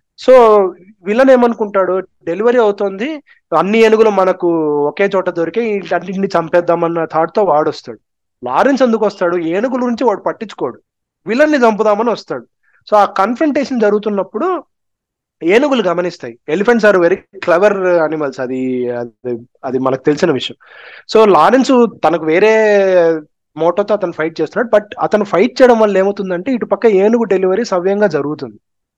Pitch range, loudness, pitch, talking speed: 160-220 Hz, -13 LUFS, 195 Hz, 135 wpm